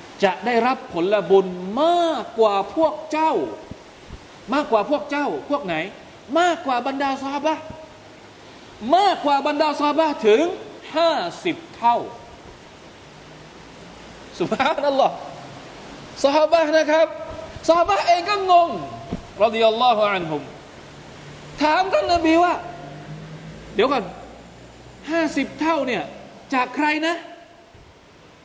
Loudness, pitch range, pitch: -20 LUFS, 235-330 Hz, 300 Hz